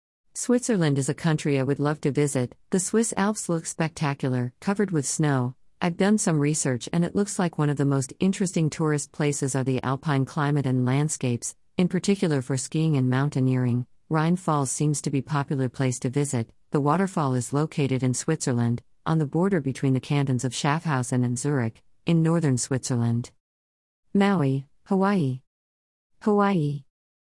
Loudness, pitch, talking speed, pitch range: -25 LUFS, 145 Hz, 170 wpm, 130-165 Hz